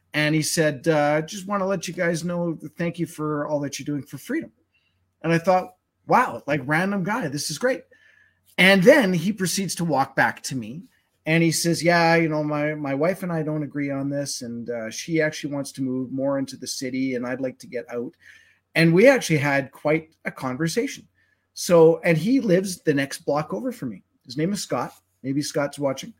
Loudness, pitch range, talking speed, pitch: -23 LUFS, 140-175 Hz, 220 wpm, 155 Hz